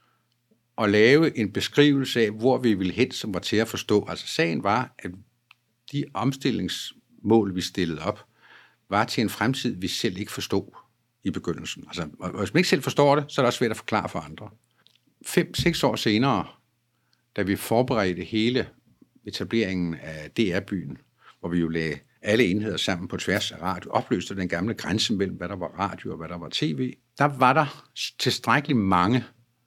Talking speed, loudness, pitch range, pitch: 180 wpm, -25 LUFS, 95-130 Hz, 115 Hz